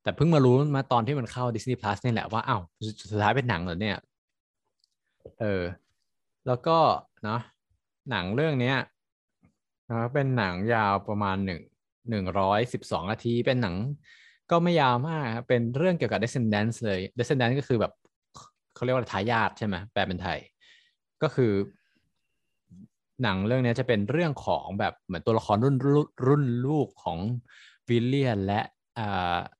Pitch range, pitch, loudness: 100-135 Hz, 120 Hz, -27 LUFS